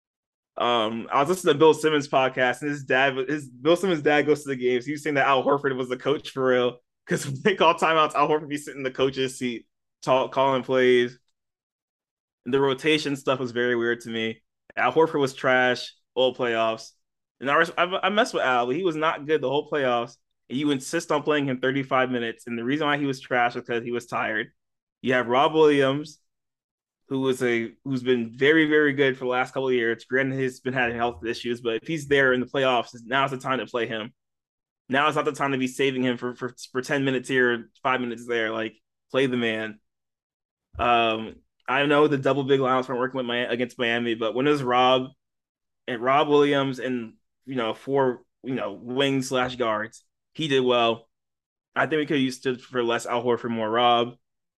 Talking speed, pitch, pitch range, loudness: 225 wpm, 130 Hz, 120-140 Hz, -24 LUFS